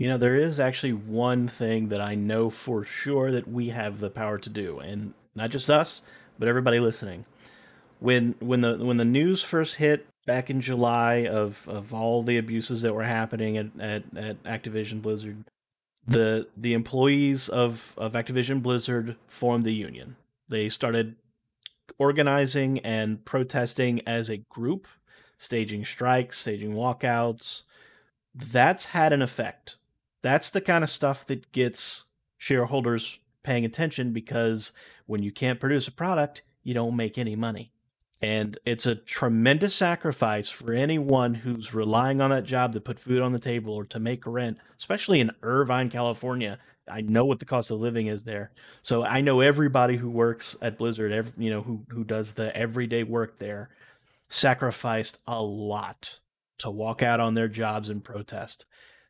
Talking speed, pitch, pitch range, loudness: 165 wpm, 120 Hz, 110-125 Hz, -26 LUFS